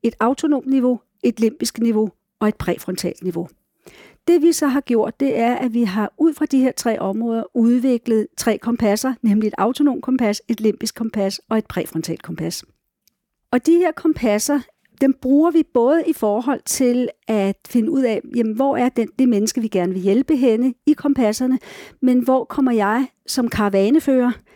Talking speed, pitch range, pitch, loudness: 180 wpm, 215-265 Hz, 235 Hz, -19 LUFS